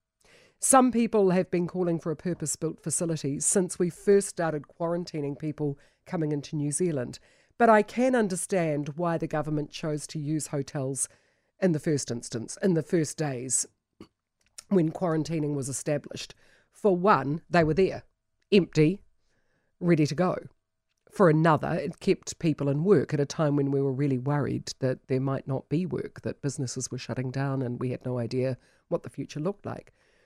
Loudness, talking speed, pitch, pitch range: -27 LUFS, 175 wpm, 155 Hz, 140-180 Hz